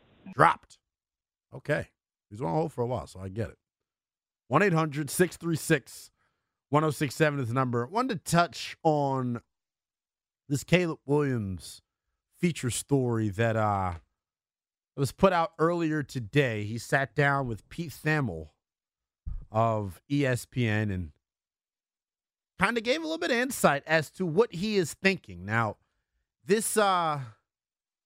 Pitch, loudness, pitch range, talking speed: 140 Hz, -28 LUFS, 110-165 Hz, 130 wpm